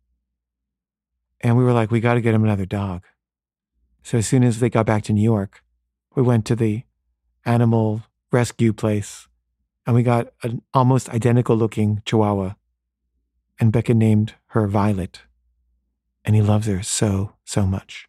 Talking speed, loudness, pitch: 160 wpm, -20 LUFS, 105 Hz